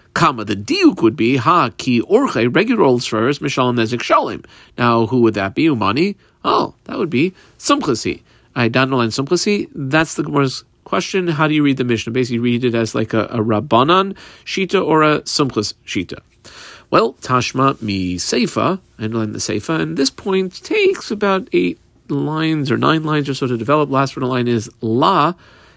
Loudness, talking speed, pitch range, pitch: -17 LUFS, 185 wpm, 115-160 Hz, 135 Hz